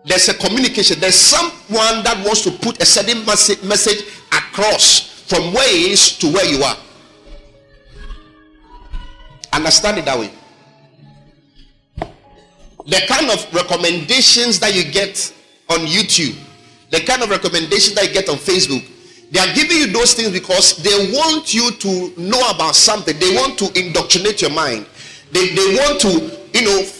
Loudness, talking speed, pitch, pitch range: -13 LUFS, 150 wpm, 195 Hz, 170-220 Hz